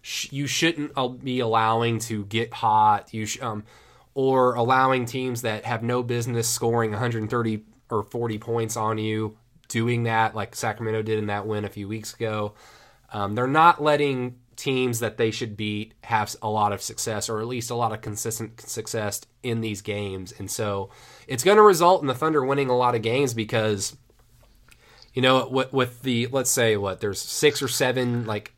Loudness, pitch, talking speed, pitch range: -24 LUFS, 115 Hz, 185 wpm, 110-125 Hz